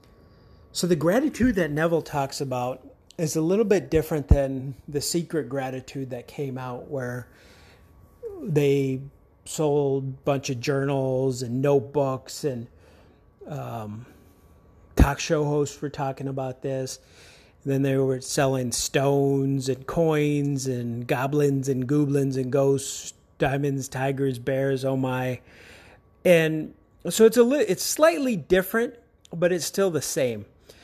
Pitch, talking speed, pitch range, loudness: 140 Hz, 135 wpm, 130-155 Hz, -25 LUFS